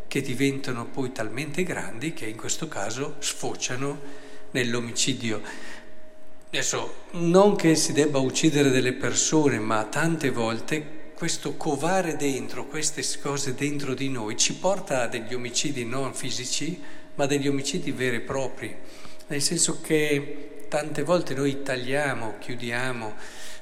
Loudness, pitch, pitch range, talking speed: -26 LUFS, 140 Hz, 125-150 Hz, 130 wpm